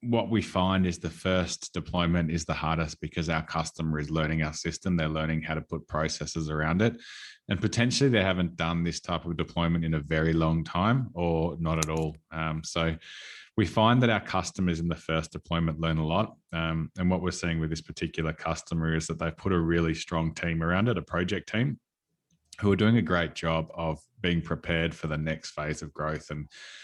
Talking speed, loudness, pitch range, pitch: 210 wpm, -29 LUFS, 80-90 Hz, 80 Hz